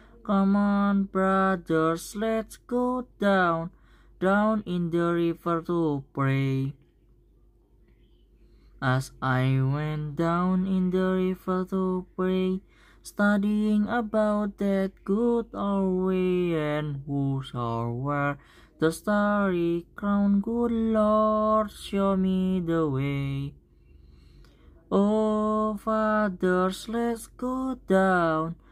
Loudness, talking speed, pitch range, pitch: -26 LUFS, 95 wpm, 155-205 Hz, 185 Hz